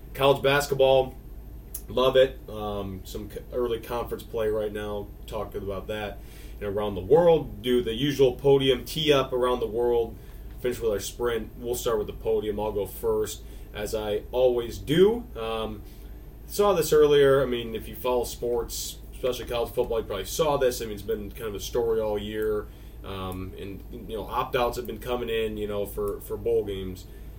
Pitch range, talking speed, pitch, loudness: 105-140 Hz, 190 wpm, 120 Hz, -26 LUFS